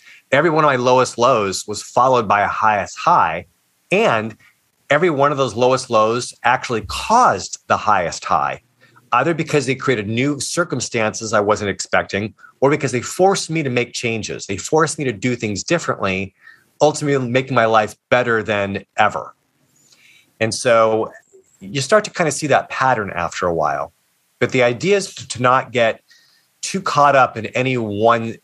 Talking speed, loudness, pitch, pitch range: 170 wpm, -17 LUFS, 125 Hz, 110-145 Hz